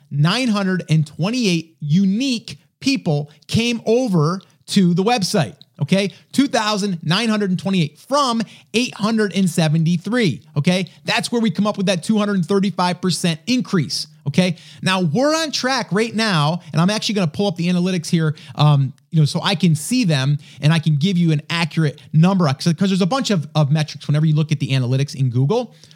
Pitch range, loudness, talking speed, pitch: 155-205 Hz, -18 LUFS, 160 wpm, 175 Hz